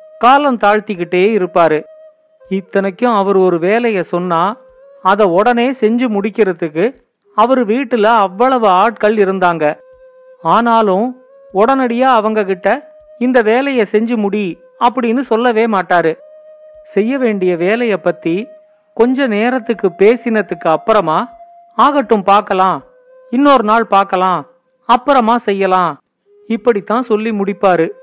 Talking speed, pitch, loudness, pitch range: 100 wpm, 225 Hz, -13 LUFS, 195-260 Hz